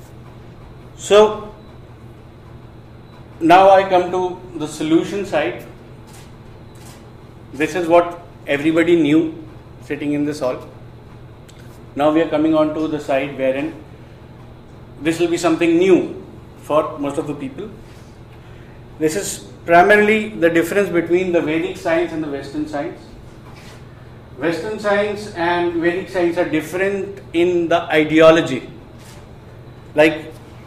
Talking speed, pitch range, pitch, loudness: 115 wpm, 120-170 Hz, 150 Hz, -17 LUFS